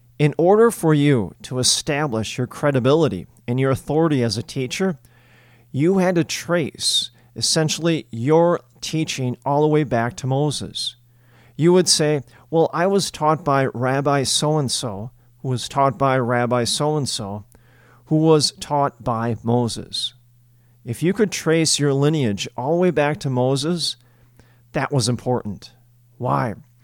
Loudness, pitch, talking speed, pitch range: -20 LUFS, 130 Hz, 150 wpm, 120-155 Hz